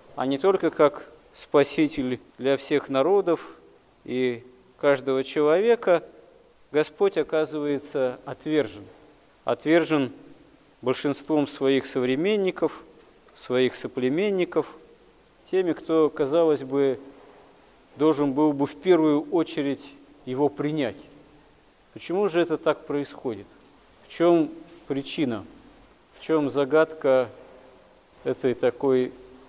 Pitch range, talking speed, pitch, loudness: 135-160 Hz, 90 wpm, 150 Hz, -24 LUFS